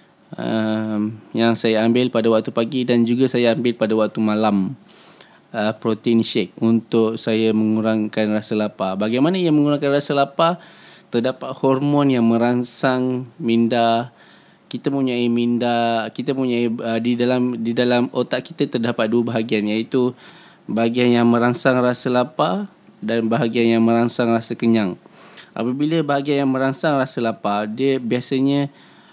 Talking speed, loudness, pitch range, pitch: 140 wpm, -19 LUFS, 115-130 Hz, 120 Hz